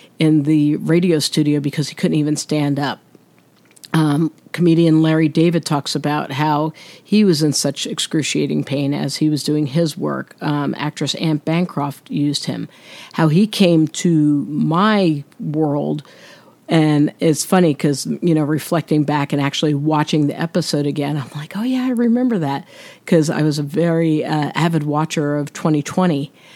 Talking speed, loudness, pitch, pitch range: 165 wpm, -18 LUFS, 155 Hz, 145-165 Hz